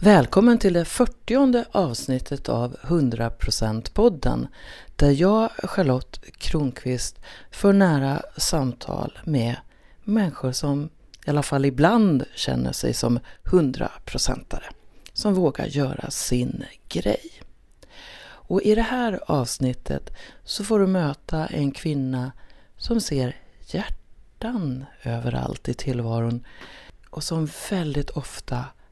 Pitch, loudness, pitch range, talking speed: 145 Hz, -23 LUFS, 125-190 Hz, 110 wpm